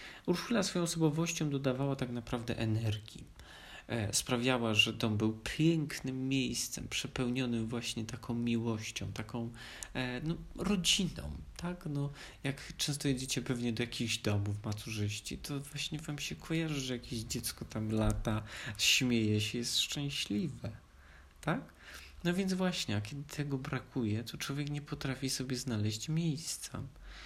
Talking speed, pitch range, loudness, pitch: 130 wpm, 110-145 Hz, -35 LUFS, 125 Hz